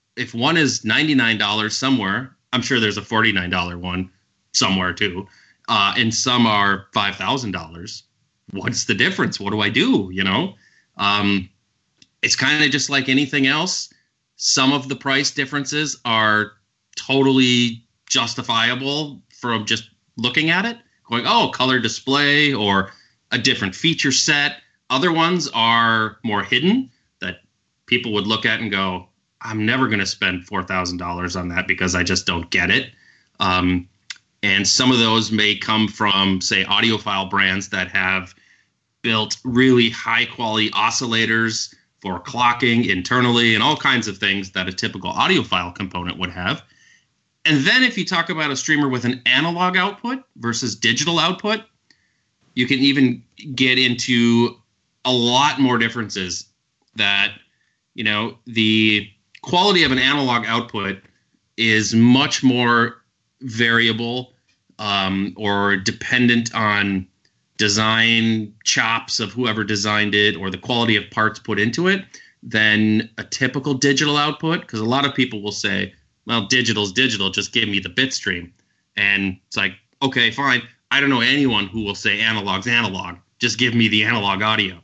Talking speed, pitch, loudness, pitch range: 150 wpm, 115 Hz, -18 LUFS, 100-130 Hz